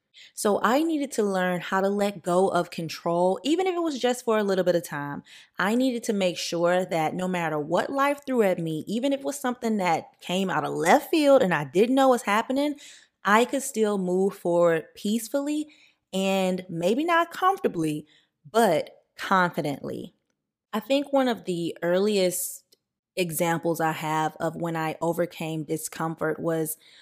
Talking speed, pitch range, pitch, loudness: 175 wpm, 170-250 Hz, 190 Hz, -25 LUFS